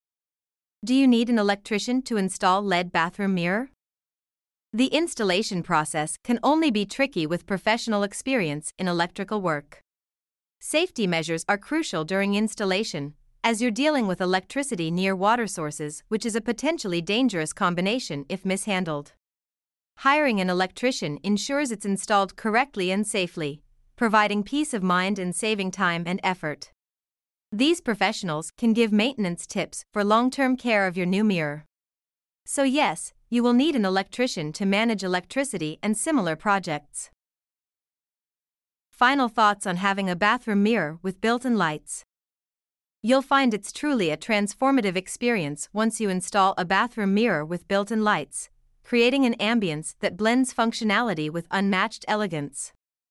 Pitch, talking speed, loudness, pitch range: 205 Hz, 145 wpm, -24 LUFS, 180-235 Hz